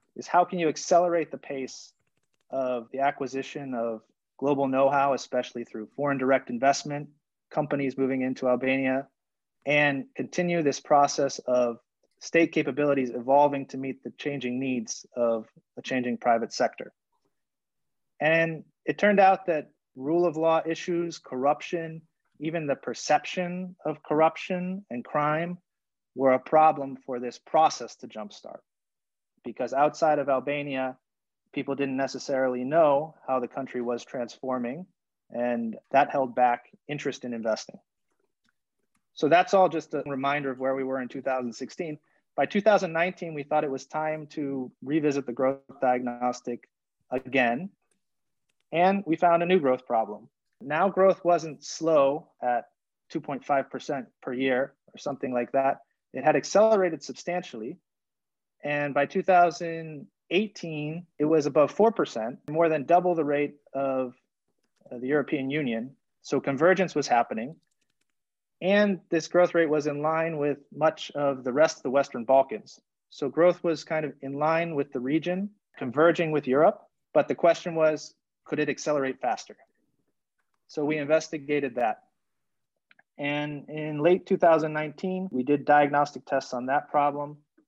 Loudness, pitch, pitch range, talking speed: -26 LUFS, 145 Hz, 130-160 Hz, 140 wpm